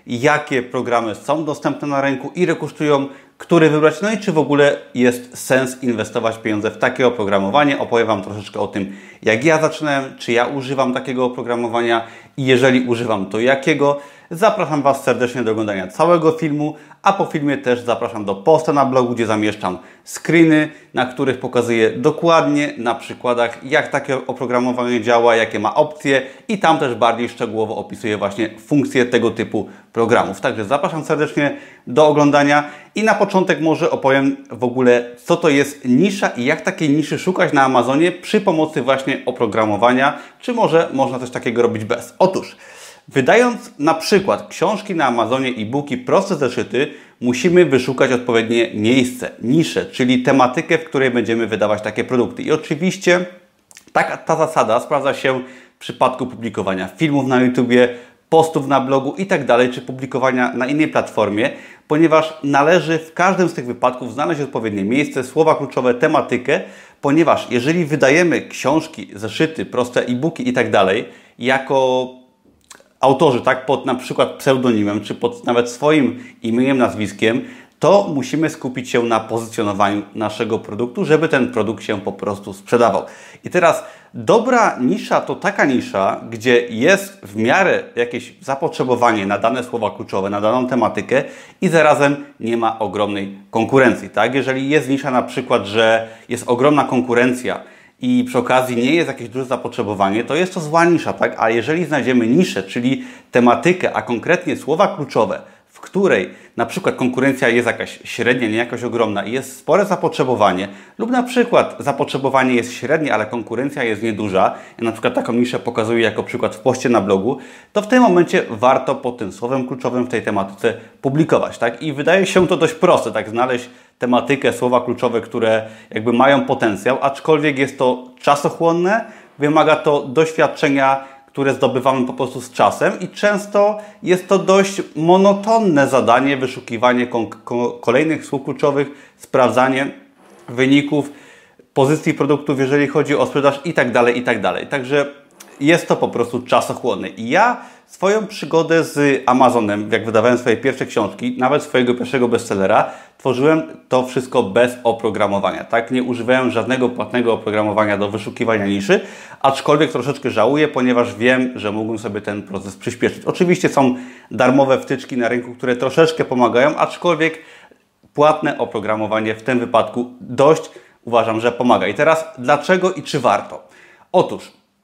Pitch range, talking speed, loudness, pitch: 120-150 Hz, 155 wpm, -17 LUFS, 130 Hz